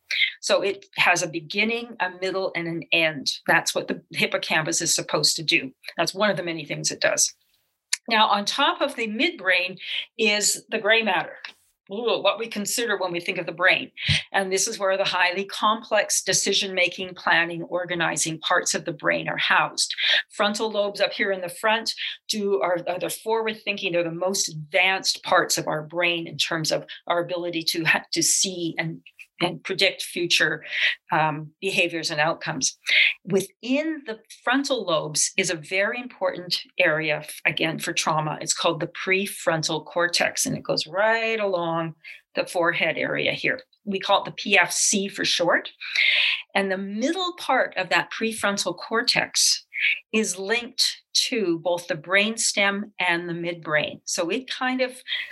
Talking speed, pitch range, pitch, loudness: 165 wpm, 170-215 Hz, 190 Hz, -23 LUFS